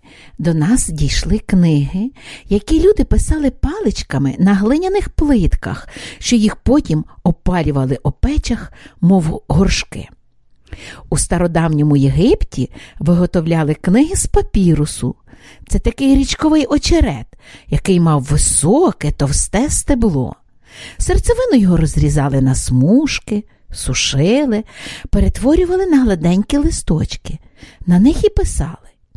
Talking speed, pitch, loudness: 100 wpm, 190 Hz, -15 LUFS